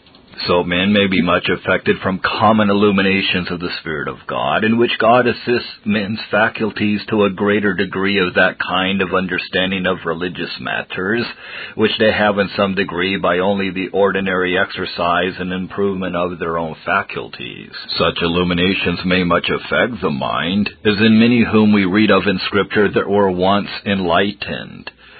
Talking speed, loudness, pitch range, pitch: 165 wpm, -16 LUFS, 90-105 Hz, 95 Hz